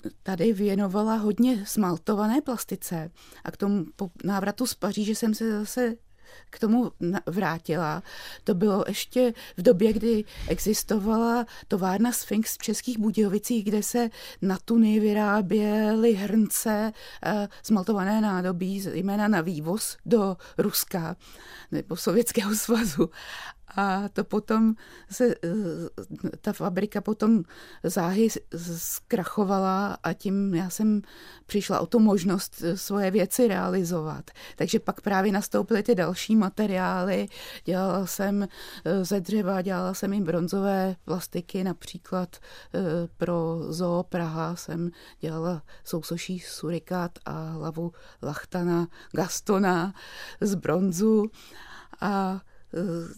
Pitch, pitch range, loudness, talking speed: 195 Hz, 175-215 Hz, -27 LUFS, 110 wpm